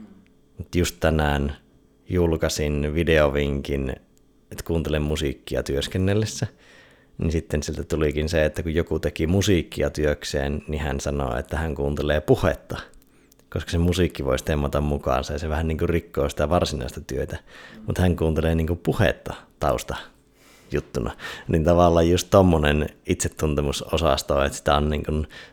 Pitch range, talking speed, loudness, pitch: 75-85 Hz, 135 wpm, -23 LUFS, 75 Hz